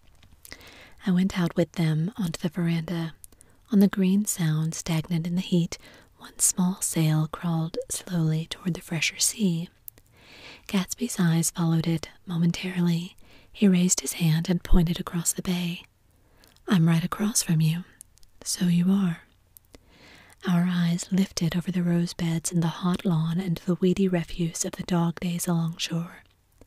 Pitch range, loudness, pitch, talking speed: 165-185 Hz, -26 LUFS, 175 Hz, 155 wpm